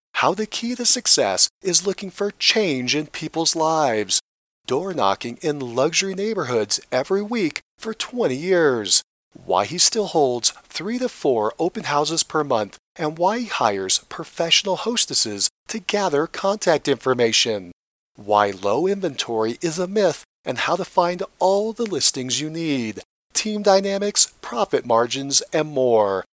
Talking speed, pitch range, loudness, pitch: 145 wpm, 130-200 Hz, -20 LUFS, 165 Hz